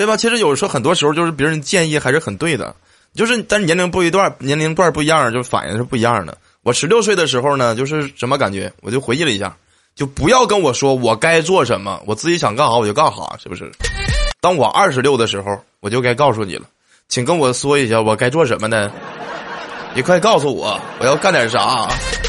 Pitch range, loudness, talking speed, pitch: 120-165 Hz, -15 LUFS, 345 characters per minute, 140 Hz